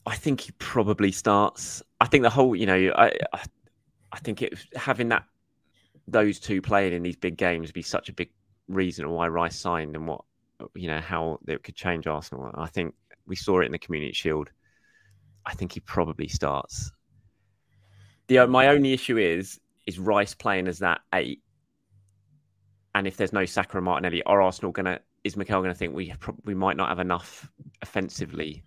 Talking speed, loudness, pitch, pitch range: 185 wpm, -26 LUFS, 95 Hz, 85-105 Hz